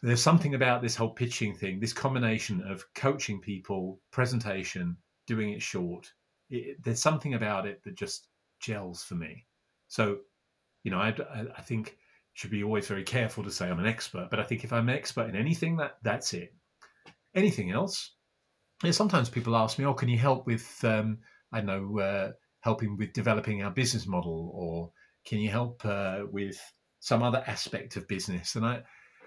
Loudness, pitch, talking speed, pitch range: -31 LUFS, 110 Hz, 185 wpm, 100-125 Hz